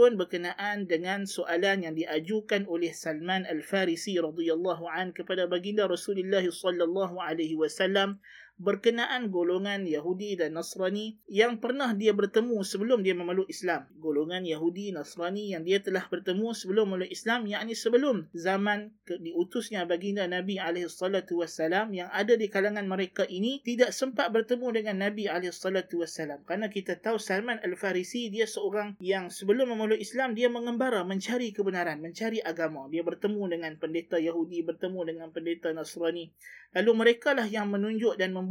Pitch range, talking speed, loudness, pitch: 170-210 Hz, 145 wpm, -30 LUFS, 190 Hz